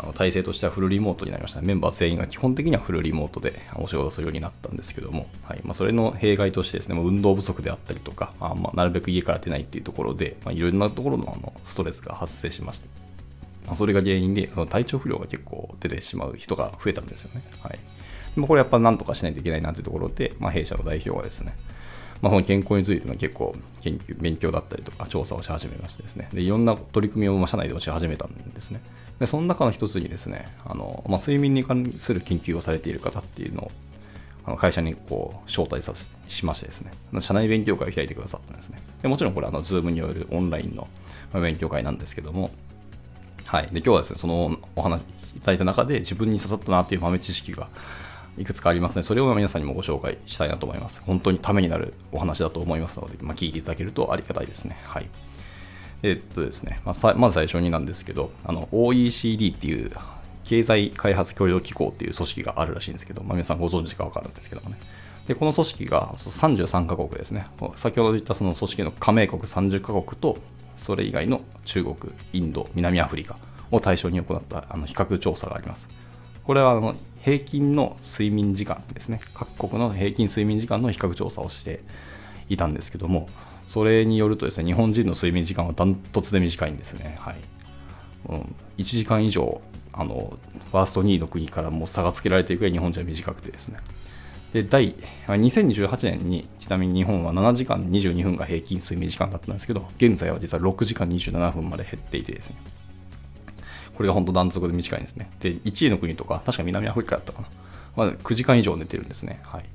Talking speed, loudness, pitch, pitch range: 425 characters per minute, -25 LUFS, 95 Hz, 85-105 Hz